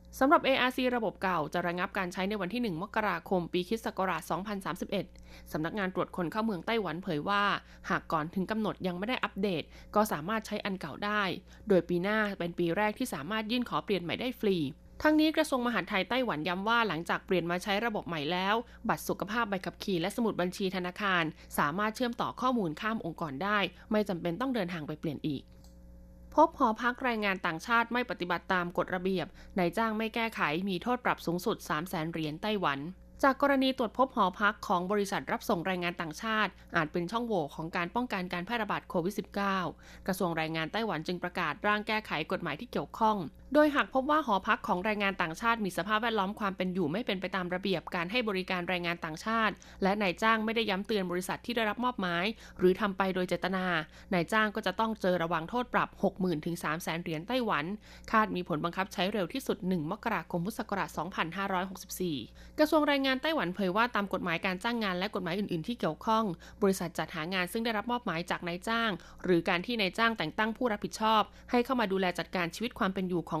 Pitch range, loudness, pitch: 175-220 Hz, -31 LUFS, 195 Hz